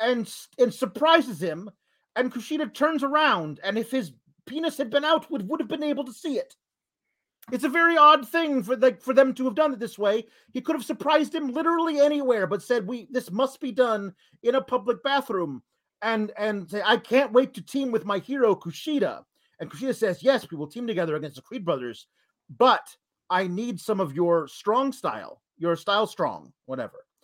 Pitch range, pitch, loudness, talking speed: 205-285 Hz, 245 Hz, -25 LUFS, 205 wpm